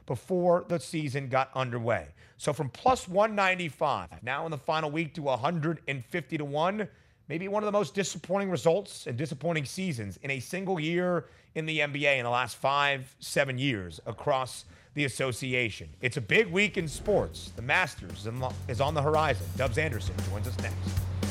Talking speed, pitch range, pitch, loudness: 170 wpm, 115-170 Hz, 145 Hz, -30 LUFS